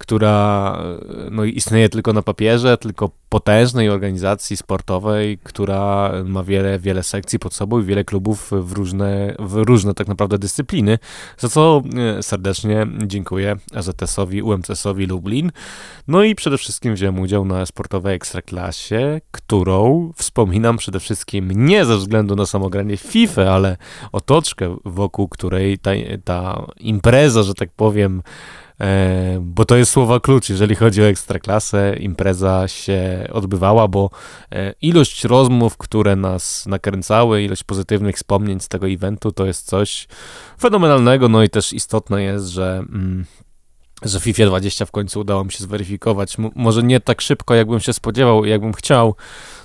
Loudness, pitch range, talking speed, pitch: -17 LUFS, 95-110 Hz, 140 wpm, 100 Hz